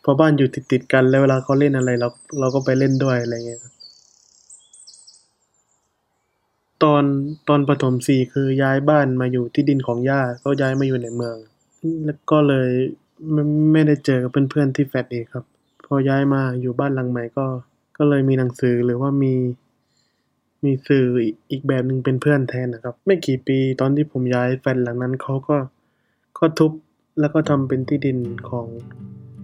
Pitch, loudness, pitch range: 135 Hz, -19 LUFS, 125-145 Hz